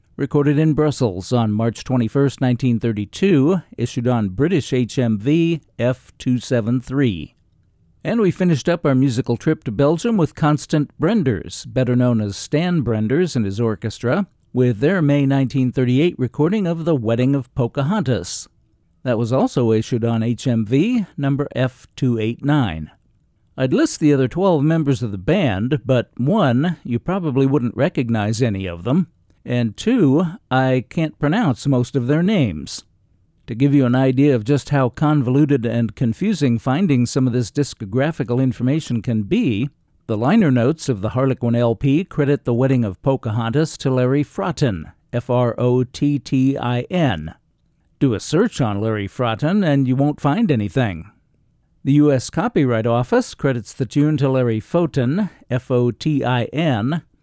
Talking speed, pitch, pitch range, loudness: 150 wpm, 130 Hz, 120-145 Hz, -19 LUFS